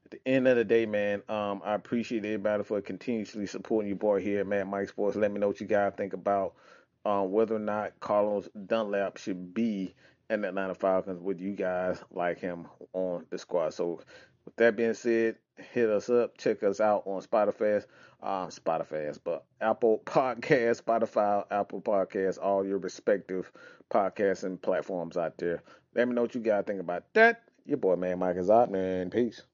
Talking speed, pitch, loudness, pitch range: 190 wpm, 100 Hz, -30 LUFS, 95-115 Hz